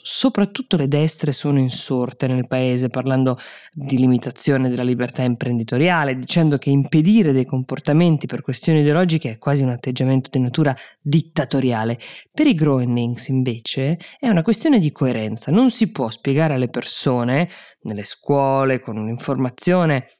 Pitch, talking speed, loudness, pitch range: 135 Hz, 145 wpm, -19 LUFS, 125-155 Hz